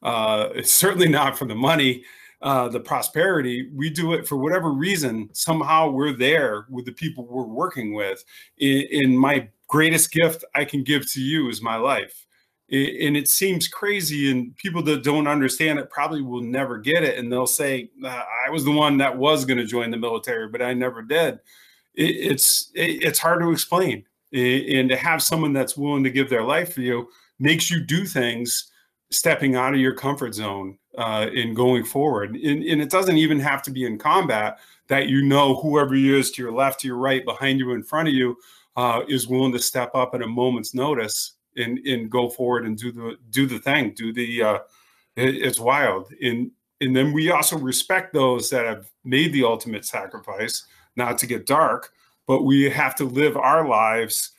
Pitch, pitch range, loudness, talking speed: 135 Hz, 125-150 Hz, -21 LUFS, 195 wpm